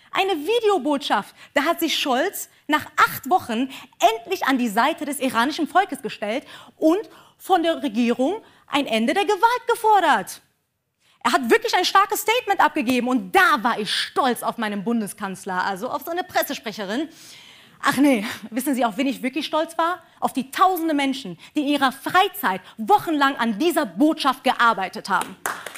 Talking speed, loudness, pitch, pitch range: 160 wpm, -21 LUFS, 290 Hz, 245-360 Hz